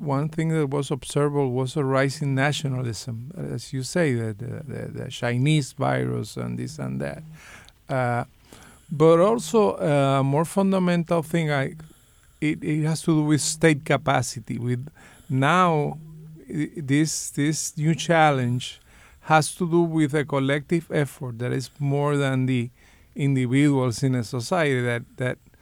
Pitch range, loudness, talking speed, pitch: 125-155 Hz, -23 LUFS, 145 wpm, 140 Hz